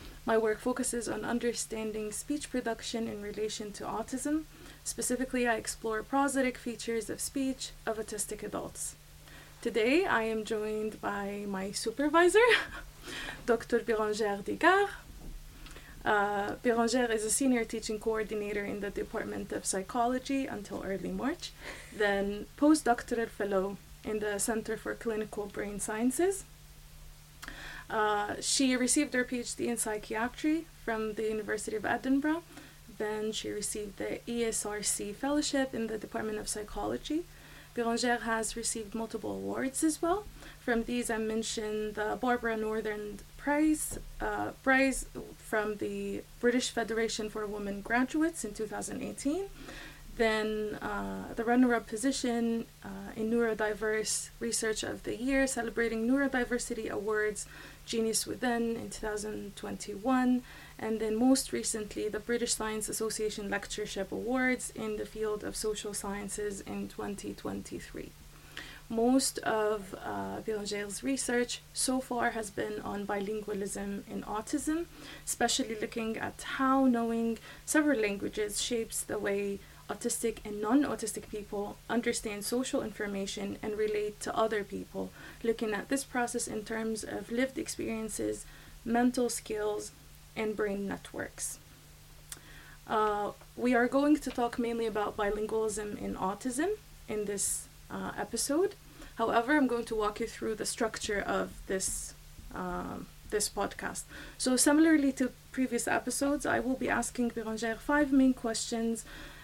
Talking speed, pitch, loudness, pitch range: 130 wpm, 225 Hz, -32 LUFS, 215-250 Hz